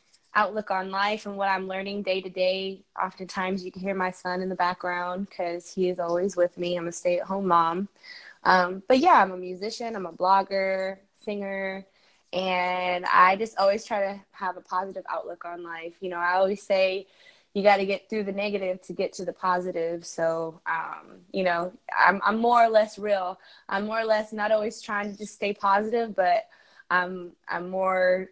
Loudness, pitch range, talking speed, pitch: -26 LUFS, 180-200 Hz, 200 wpm, 190 Hz